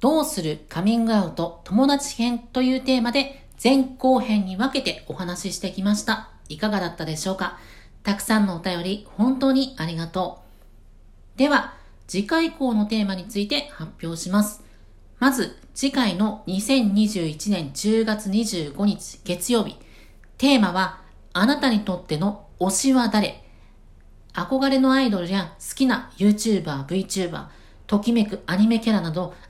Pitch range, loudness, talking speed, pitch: 185-250 Hz, -23 LUFS, 300 characters per minute, 210 Hz